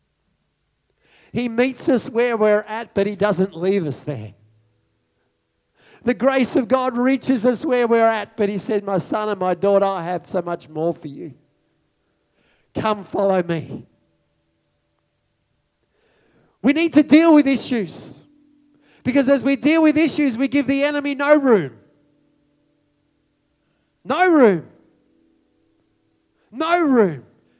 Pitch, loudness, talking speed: 215 Hz, -19 LUFS, 135 wpm